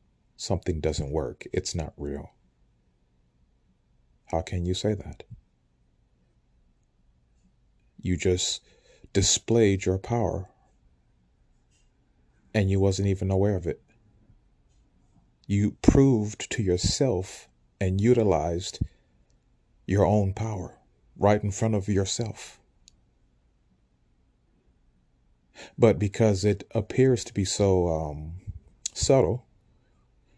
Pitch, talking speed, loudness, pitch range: 90 Hz, 90 wpm, -26 LUFS, 60-100 Hz